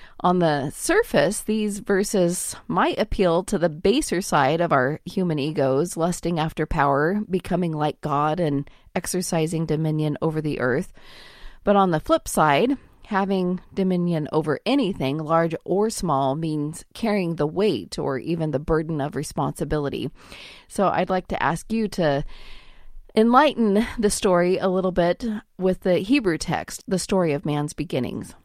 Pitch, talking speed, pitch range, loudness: 170 Hz, 150 wpm, 155-195 Hz, -23 LUFS